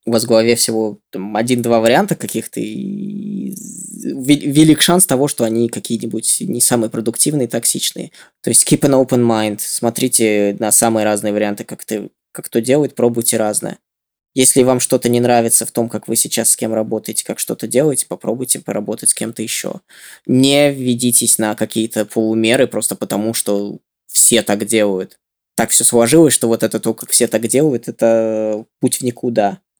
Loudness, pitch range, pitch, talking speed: -14 LUFS, 110-130 Hz, 115 Hz, 170 wpm